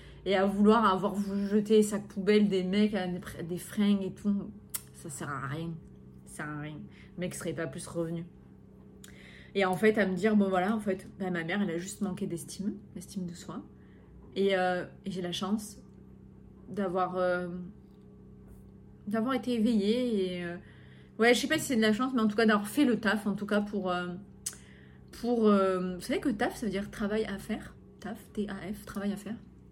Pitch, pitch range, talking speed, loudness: 195 Hz, 180-215 Hz, 205 wpm, -30 LUFS